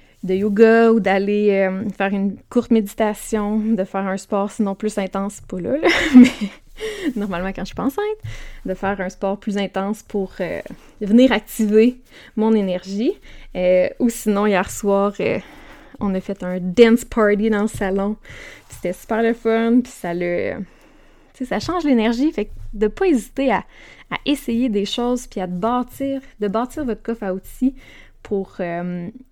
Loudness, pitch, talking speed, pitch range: -19 LUFS, 215 Hz, 175 wpm, 195-245 Hz